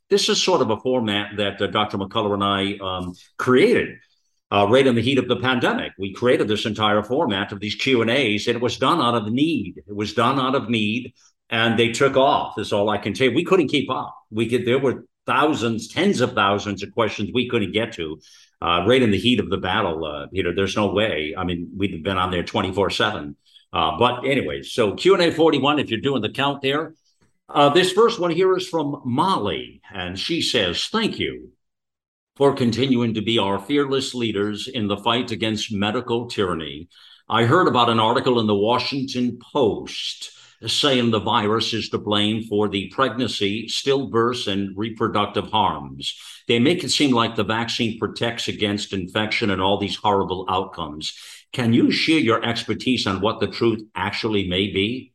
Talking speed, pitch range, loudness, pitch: 195 wpm, 100-125 Hz, -21 LUFS, 110 Hz